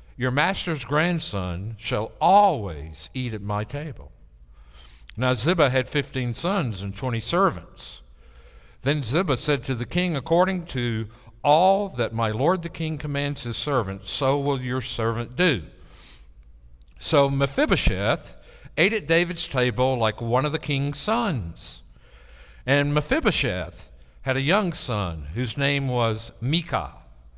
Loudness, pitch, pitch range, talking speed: -24 LUFS, 125 Hz, 95-150 Hz, 135 wpm